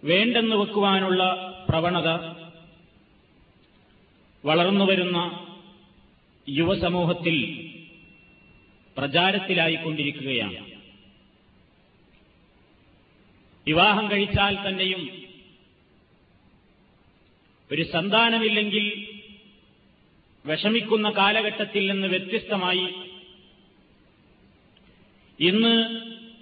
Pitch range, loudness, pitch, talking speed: 165-205 Hz, -23 LUFS, 185 Hz, 35 wpm